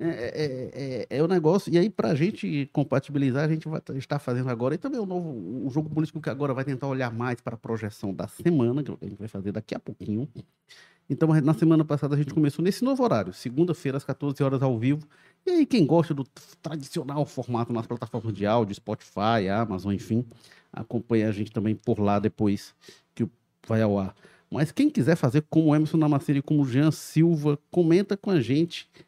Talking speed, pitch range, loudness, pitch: 215 wpm, 115-160 Hz, -26 LUFS, 140 Hz